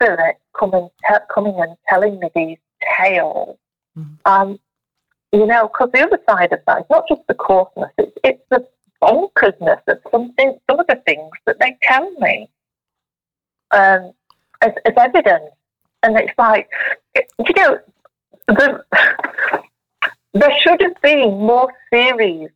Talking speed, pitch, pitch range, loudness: 140 wpm, 225 Hz, 195-285 Hz, -15 LUFS